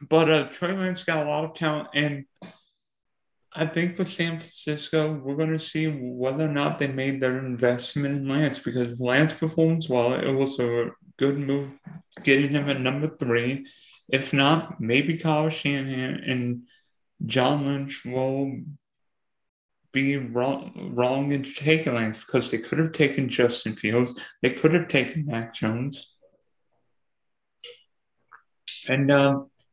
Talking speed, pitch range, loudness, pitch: 145 wpm, 130-155 Hz, -25 LUFS, 140 Hz